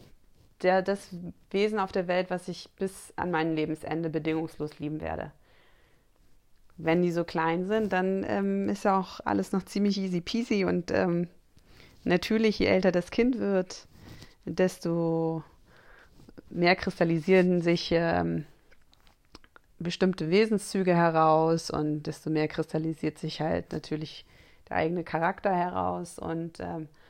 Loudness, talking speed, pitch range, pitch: -28 LUFS, 130 wpm, 160-190 Hz, 175 Hz